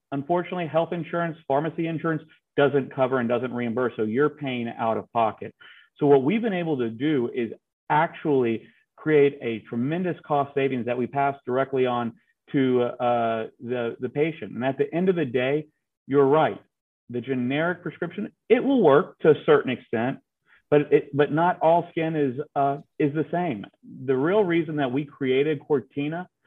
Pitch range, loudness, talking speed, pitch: 130-165 Hz, -24 LUFS, 175 wpm, 145 Hz